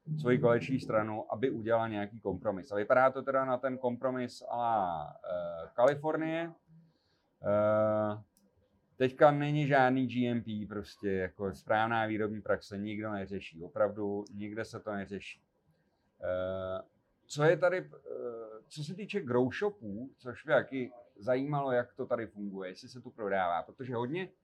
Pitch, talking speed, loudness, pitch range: 120 Hz, 140 wpm, -33 LUFS, 105-135 Hz